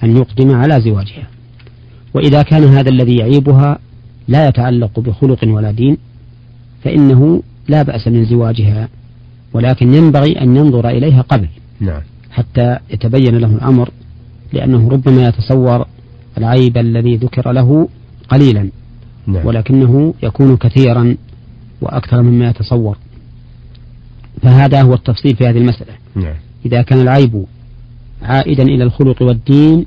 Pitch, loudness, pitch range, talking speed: 120 Hz, -11 LUFS, 115-130 Hz, 110 wpm